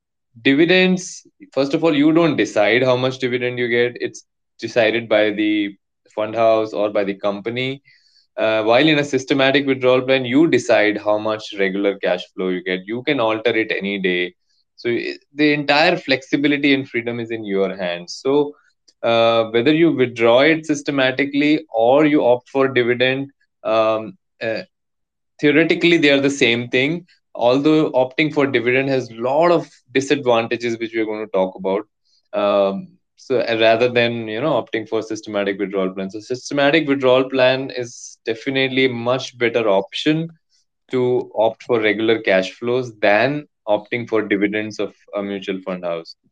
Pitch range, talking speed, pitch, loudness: 110-140 Hz, 160 wpm, 125 Hz, -18 LUFS